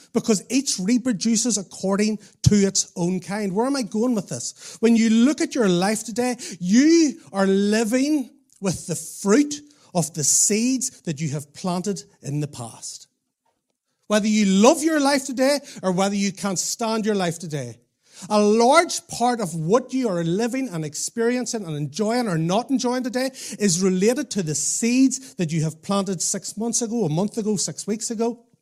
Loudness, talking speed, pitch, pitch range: -22 LUFS, 180 wpm, 210 Hz, 180-245 Hz